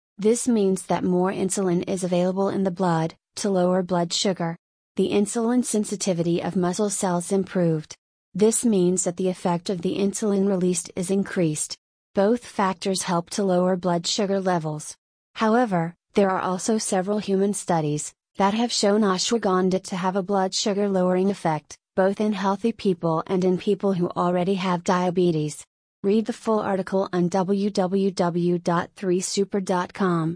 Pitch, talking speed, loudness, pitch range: 190 Hz, 150 wpm, -23 LUFS, 180-200 Hz